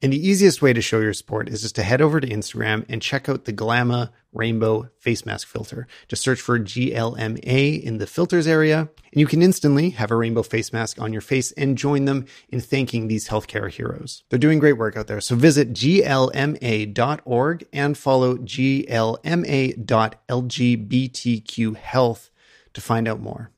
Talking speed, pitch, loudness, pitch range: 175 wpm, 120 Hz, -21 LUFS, 110-140 Hz